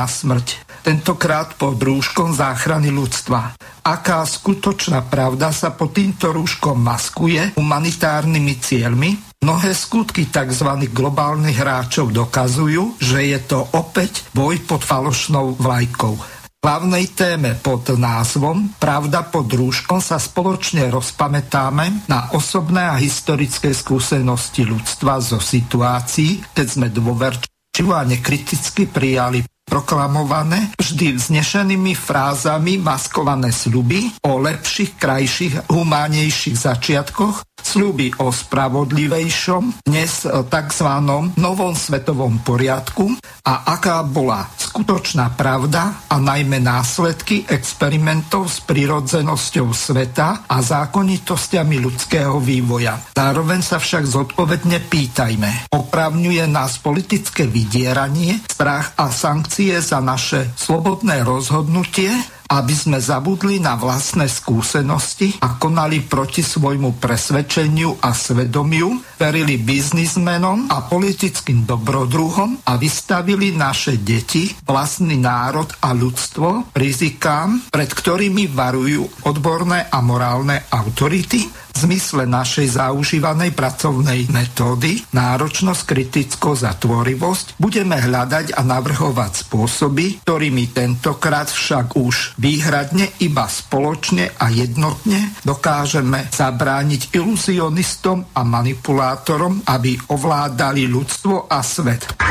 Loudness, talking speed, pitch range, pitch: -17 LUFS, 105 wpm, 130-170 Hz, 145 Hz